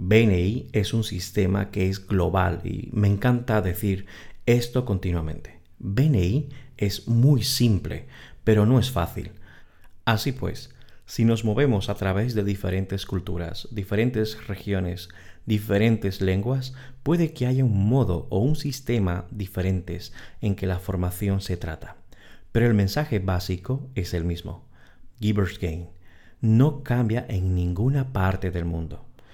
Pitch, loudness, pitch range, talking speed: 100 Hz, -25 LUFS, 90-120 Hz, 135 wpm